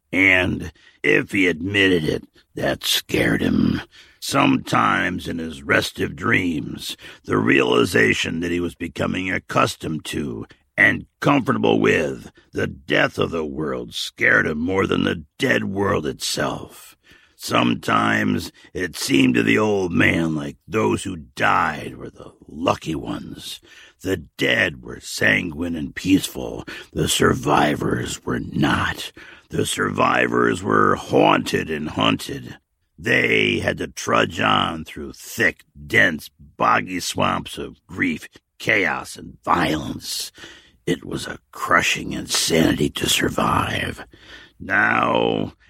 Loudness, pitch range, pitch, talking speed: -20 LUFS, 70-85 Hz, 80 Hz, 120 wpm